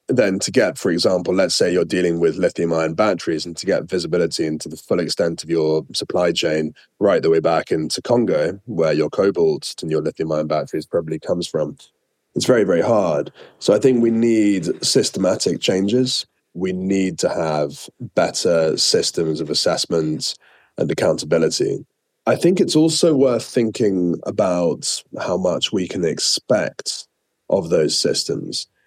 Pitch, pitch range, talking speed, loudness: 95 Hz, 80-130 Hz, 160 wpm, -19 LUFS